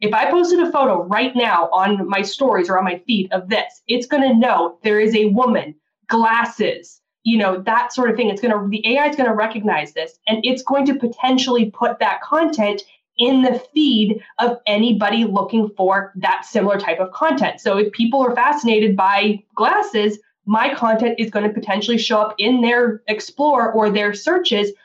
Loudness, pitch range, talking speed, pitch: -17 LUFS, 205-245 Hz, 190 wpm, 225 Hz